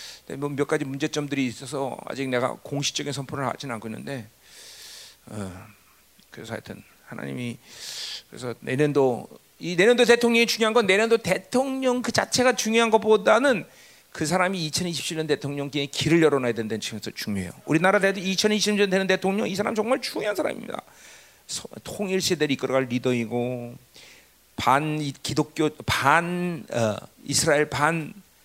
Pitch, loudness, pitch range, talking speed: 150 Hz, -24 LUFS, 130-195 Hz, 315 characters per minute